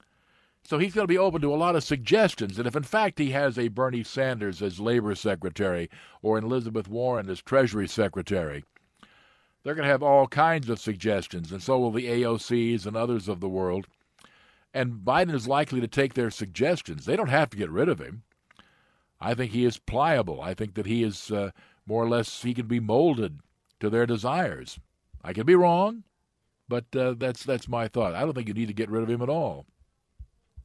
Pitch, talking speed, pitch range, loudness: 120 Hz, 210 wpm, 110-135 Hz, -26 LUFS